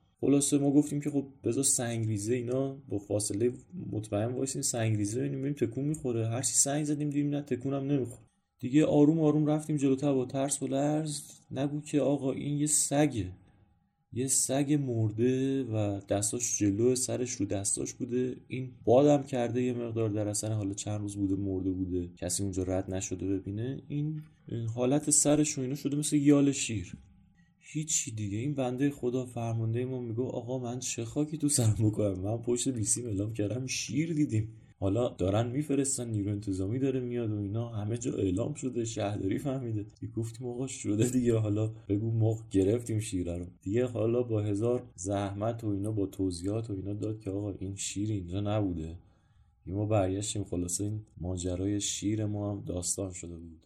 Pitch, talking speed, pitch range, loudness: 115 Hz, 175 wpm, 100-135 Hz, -31 LUFS